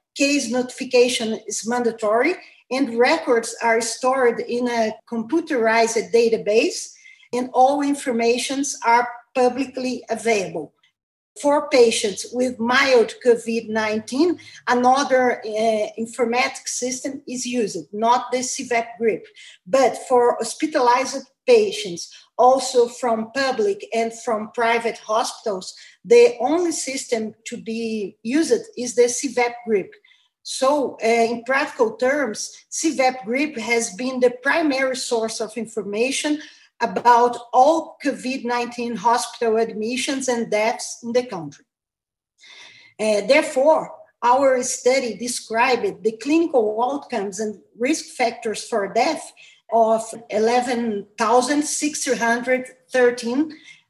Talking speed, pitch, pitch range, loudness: 105 wpm, 245 Hz, 230-270 Hz, -20 LUFS